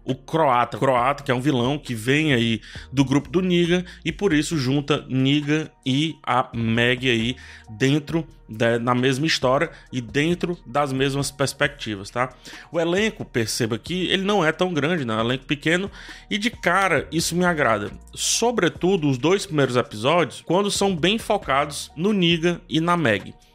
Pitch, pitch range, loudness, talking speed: 145 Hz, 125-175 Hz, -22 LUFS, 175 wpm